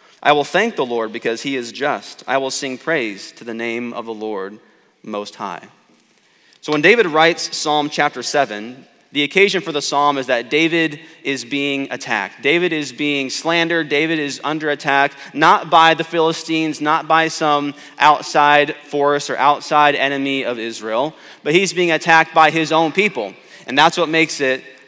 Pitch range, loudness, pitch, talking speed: 135-160 Hz, -16 LUFS, 145 Hz, 180 wpm